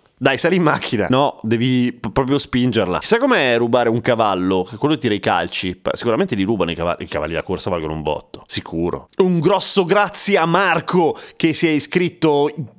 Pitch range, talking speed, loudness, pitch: 100-165 Hz, 190 wpm, -18 LUFS, 125 Hz